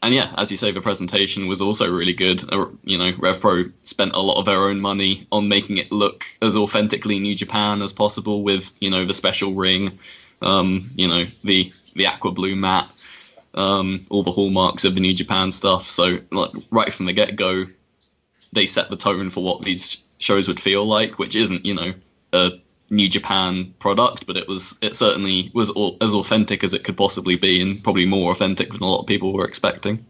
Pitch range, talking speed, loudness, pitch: 95-100 Hz, 210 wpm, -19 LUFS, 95 Hz